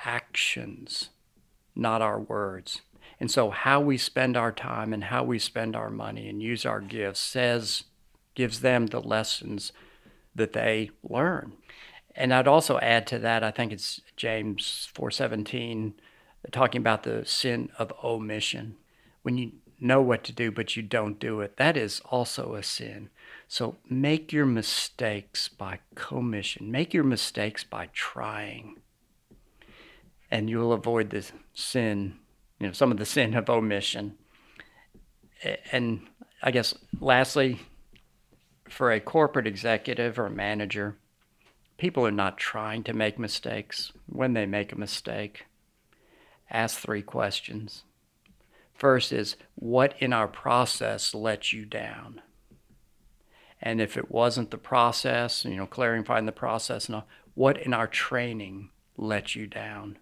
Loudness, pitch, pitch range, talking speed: -28 LUFS, 115 Hz, 105-125 Hz, 140 wpm